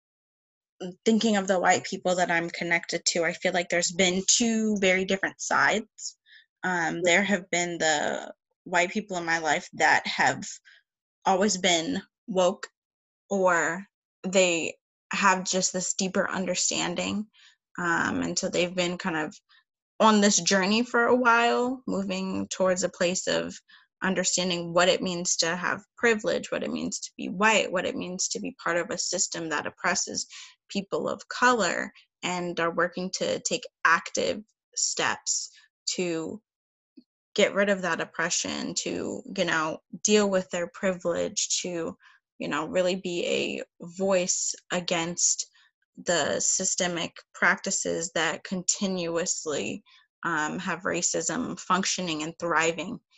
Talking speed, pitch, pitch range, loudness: 140 wpm, 185 Hz, 175-215 Hz, -26 LUFS